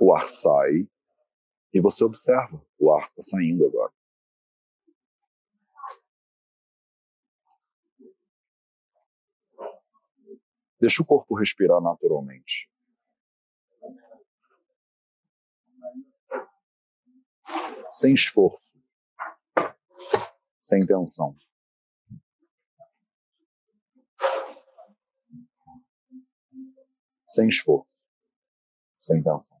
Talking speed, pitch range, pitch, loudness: 50 wpm, 225-335 Hz, 265 Hz, -23 LUFS